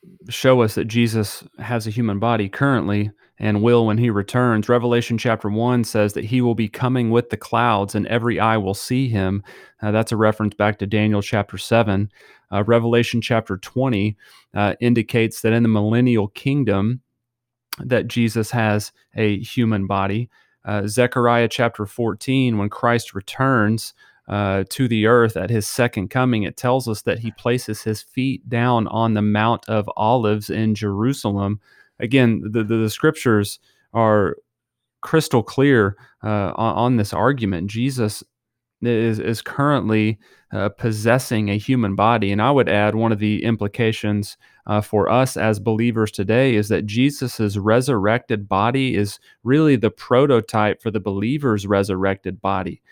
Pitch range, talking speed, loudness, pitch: 105-120 Hz, 160 wpm, -20 LUFS, 110 Hz